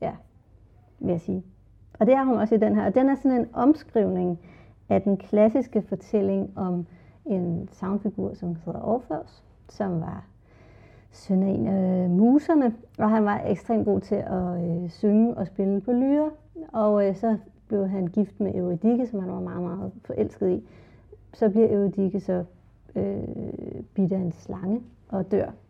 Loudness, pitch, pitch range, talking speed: -25 LUFS, 195 Hz, 180-220 Hz, 175 wpm